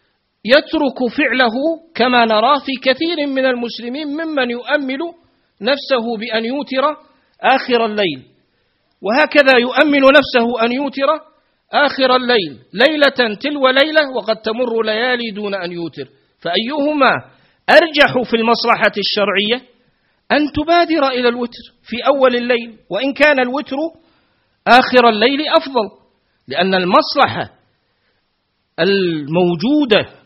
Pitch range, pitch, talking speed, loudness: 225-290 Hz, 250 Hz, 105 wpm, -15 LUFS